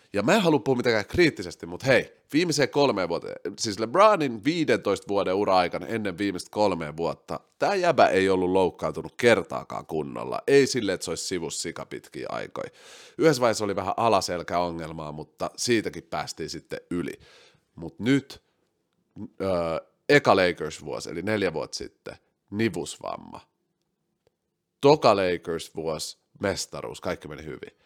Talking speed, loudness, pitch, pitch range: 140 wpm, -25 LUFS, 105 Hz, 90-140 Hz